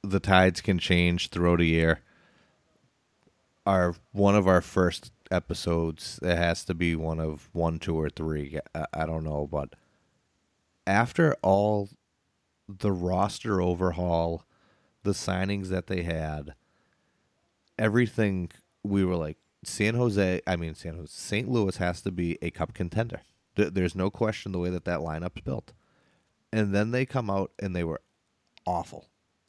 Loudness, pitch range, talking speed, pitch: -28 LUFS, 85-100 Hz, 145 wpm, 90 Hz